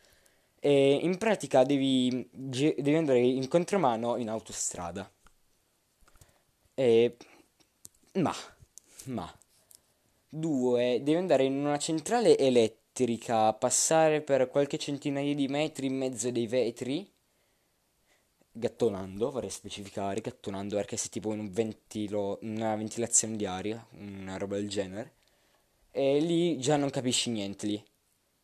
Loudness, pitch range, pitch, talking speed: -29 LUFS, 105-140 Hz, 120 Hz, 120 wpm